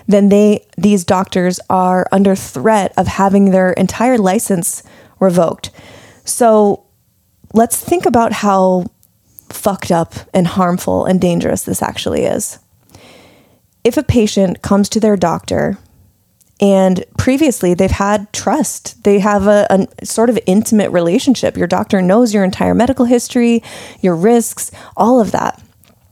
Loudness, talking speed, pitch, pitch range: -13 LUFS, 135 wpm, 195 Hz, 185-220 Hz